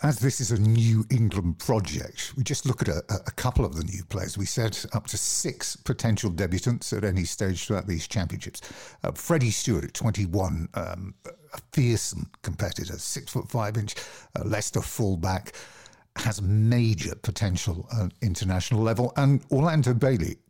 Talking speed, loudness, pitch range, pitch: 160 wpm, -27 LUFS, 95-125 Hz, 110 Hz